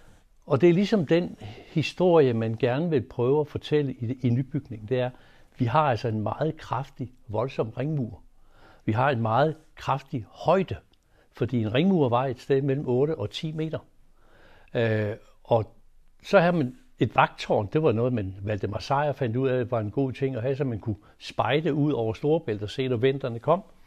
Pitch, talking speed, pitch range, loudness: 130 Hz, 195 wpm, 115-150 Hz, -26 LUFS